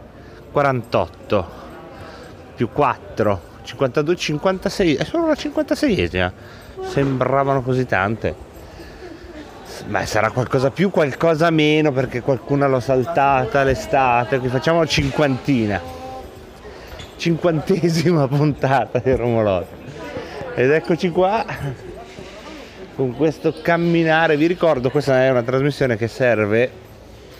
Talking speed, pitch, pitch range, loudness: 95 wpm, 140 Hz, 125-165 Hz, -19 LUFS